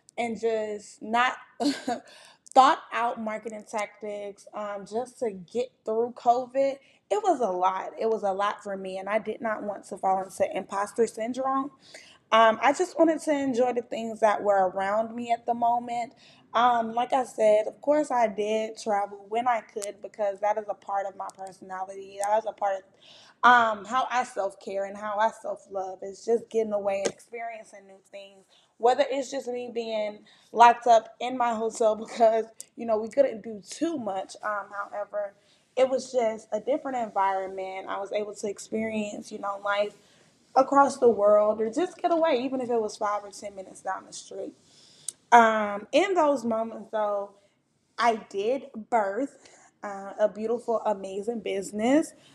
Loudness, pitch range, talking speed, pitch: -27 LUFS, 205-245 Hz, 180 wpm, 220 Hz